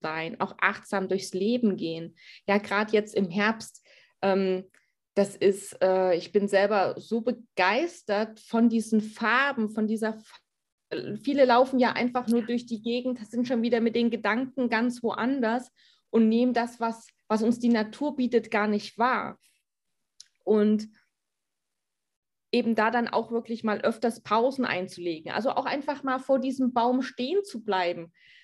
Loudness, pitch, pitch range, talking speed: -27 LUFS, 225 Hz, 205-245 Hz, 160 wpm